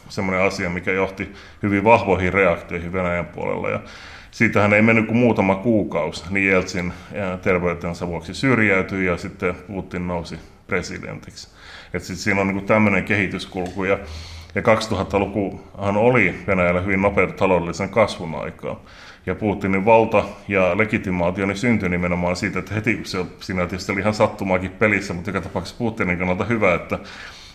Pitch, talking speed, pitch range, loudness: 95 Hz, 140 wpm, 90-105 Hz, -20 LUFS